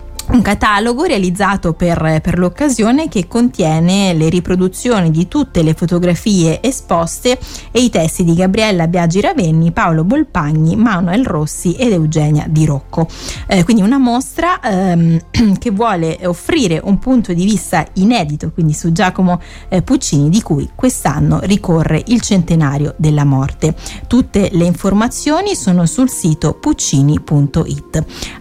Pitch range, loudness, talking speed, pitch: 165-230 Hz, -13 LUFS, 130 wpm, 180 Hz